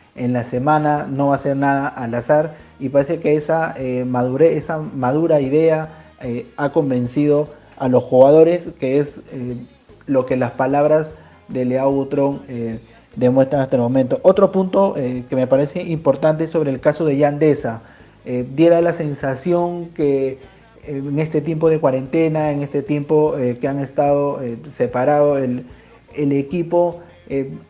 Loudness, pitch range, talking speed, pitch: -18 LUFS, 130-155 Hz, 165 wpm, 140 Hz